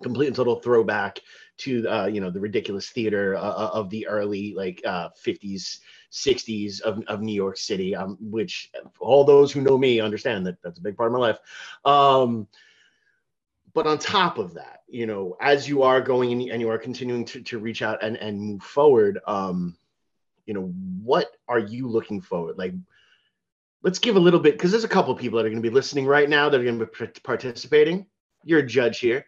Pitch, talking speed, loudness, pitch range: 115 Hz, 210 wpm, -23 LUFS, 105-140 Hz